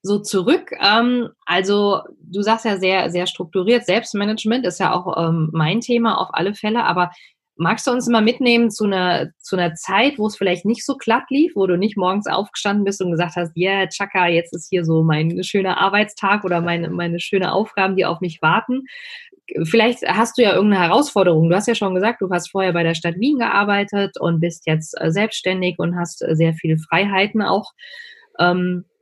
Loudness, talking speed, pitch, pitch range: -18 LUFS, 190 wpm, 195 Hz, 175-220 Hz